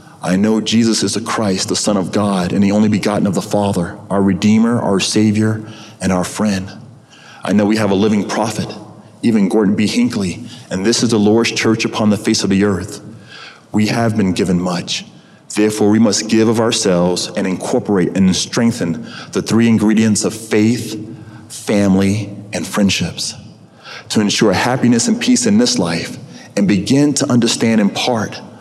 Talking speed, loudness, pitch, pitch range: 175 wpm, -15 LUFS, 110 Hz, 100-115 Hz